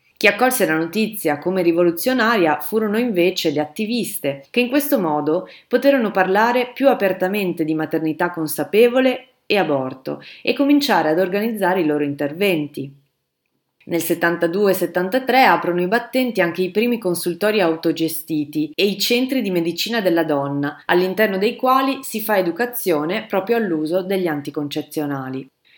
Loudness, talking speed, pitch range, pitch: -19 LUFS, 135 wpm, 160-225 Hz, 185 Hz